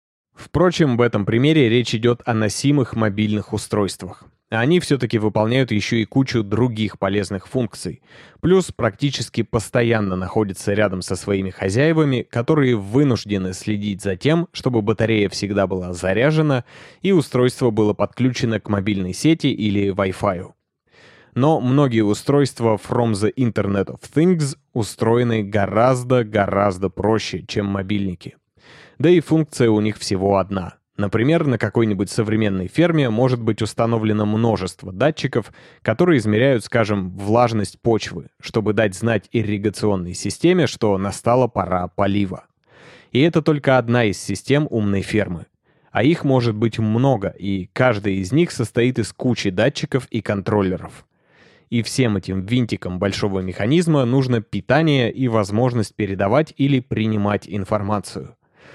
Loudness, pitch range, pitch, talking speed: -19 LUFS, 100-130 Hz, 110 Hz, 130 wpm